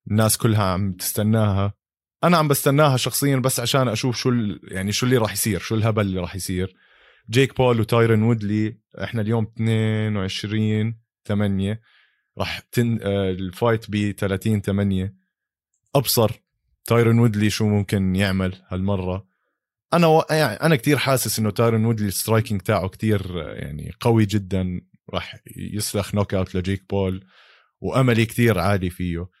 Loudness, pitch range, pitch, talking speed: -21 LUFS, 95-115 Hz, 105 Hz, 145 wpm